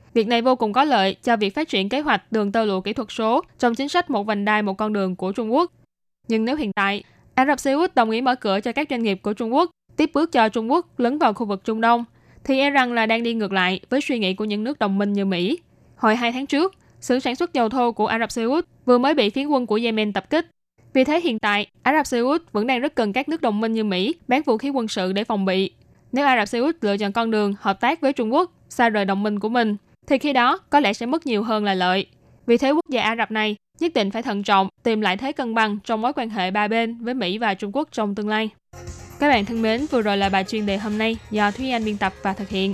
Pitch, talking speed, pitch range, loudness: 230 Hz, 295 wpm, 210-265 Hz, -21 LUFS